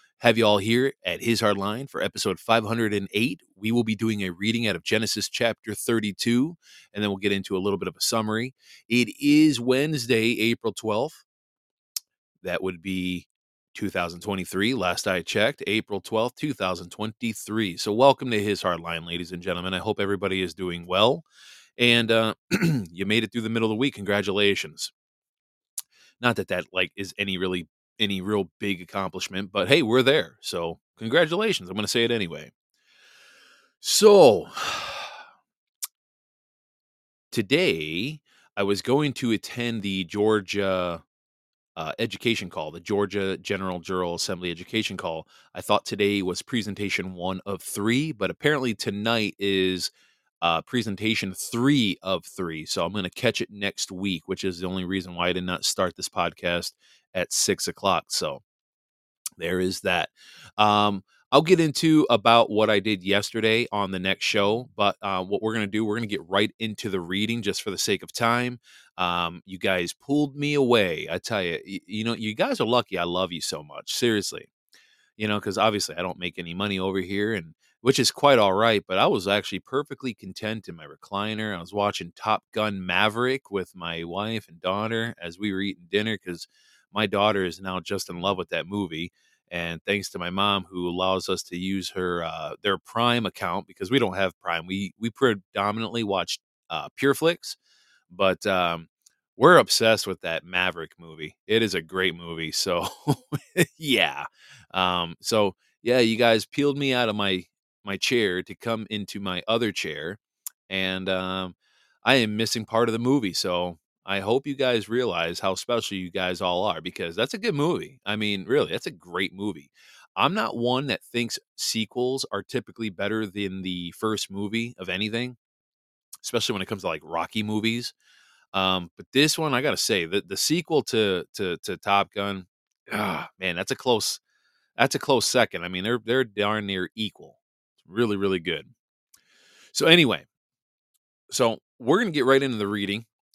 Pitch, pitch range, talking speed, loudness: 100 Hz, 95-115 Hz, 180 wpm, -25 LUFS